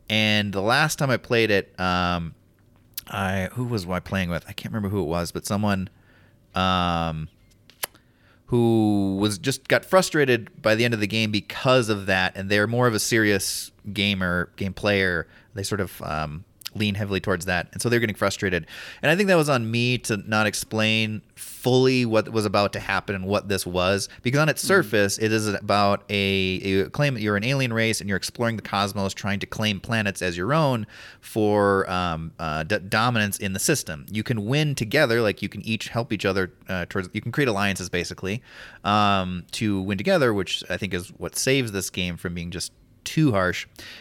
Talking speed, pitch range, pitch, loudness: 205 wpm, 95-115 Hz, 105 Hz, -23 LUFS